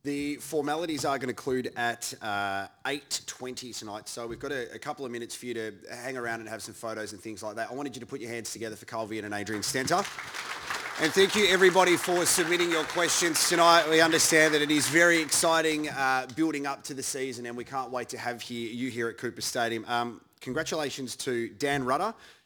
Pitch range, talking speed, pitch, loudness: 115-155 Hz, 225 wpm, 130 Hz, -27 LUFS